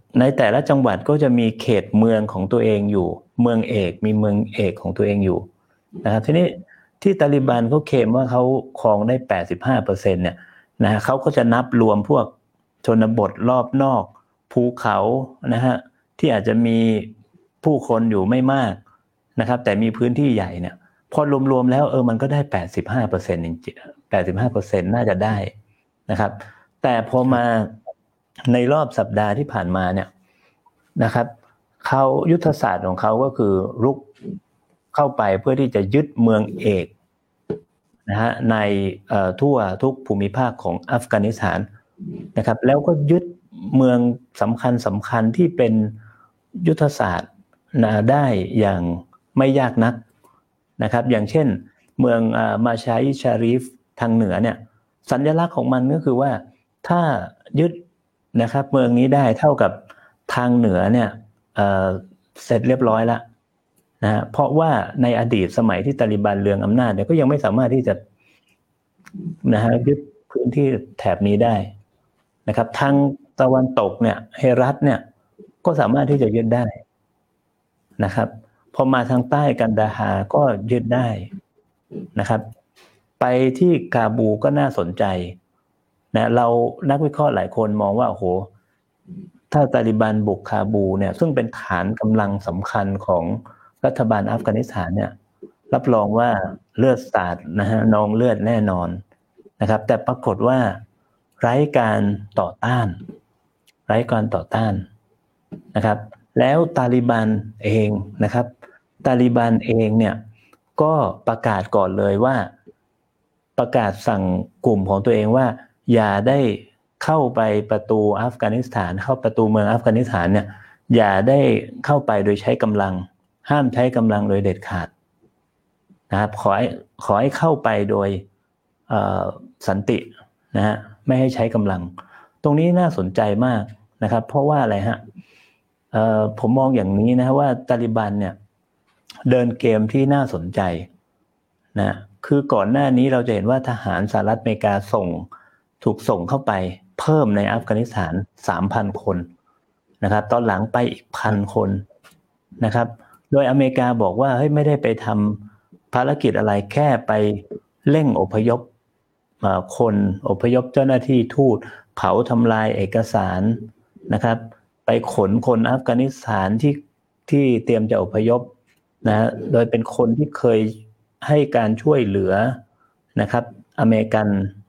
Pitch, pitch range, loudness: 115 Hz, 105-130 Hz, -19 LUFS